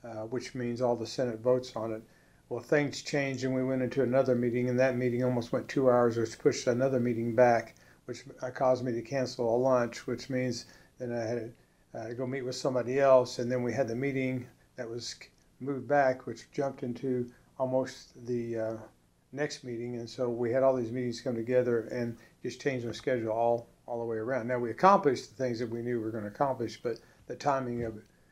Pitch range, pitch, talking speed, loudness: 115-130 Hz, 125 Hz, 225 wpm, -31 LUFS